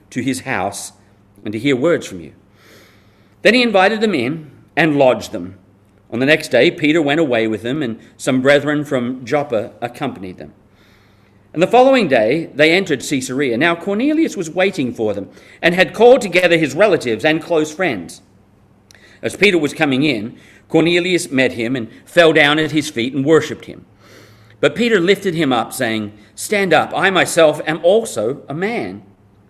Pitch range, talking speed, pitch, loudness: 105-165 Hz, 175 wpm, 135 Hz, -15 LUFS